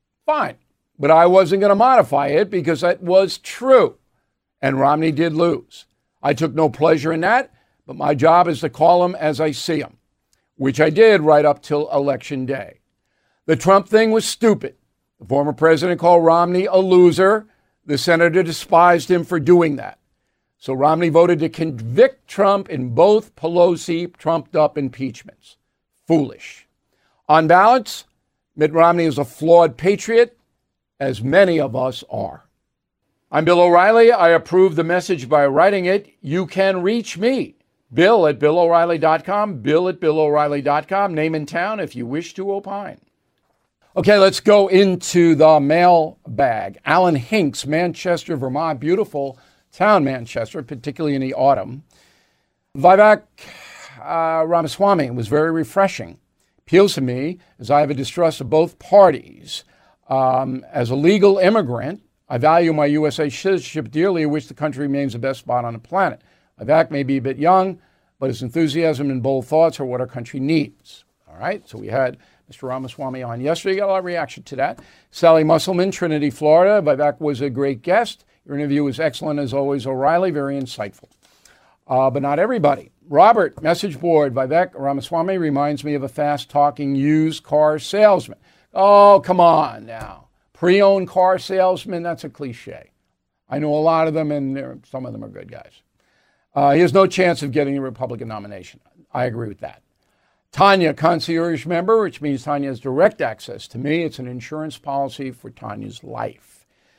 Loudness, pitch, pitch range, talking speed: -17 LUFS, 160 Hz, 140-180 Hz, 165 wpm